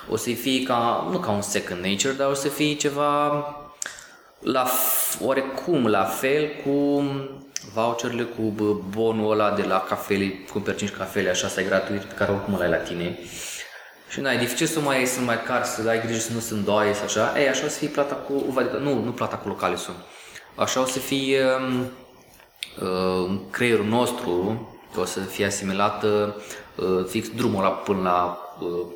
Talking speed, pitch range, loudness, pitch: 190 wpm, 100-135 Hz, -24 LUFS, 115 Hz